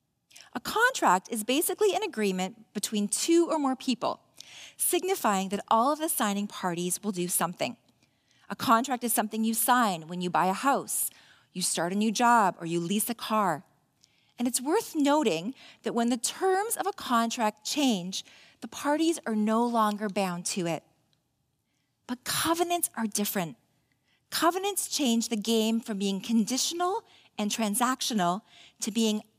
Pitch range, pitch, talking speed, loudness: 195-260 Hz, 225 Hz, 155 wpm, -28 LUFS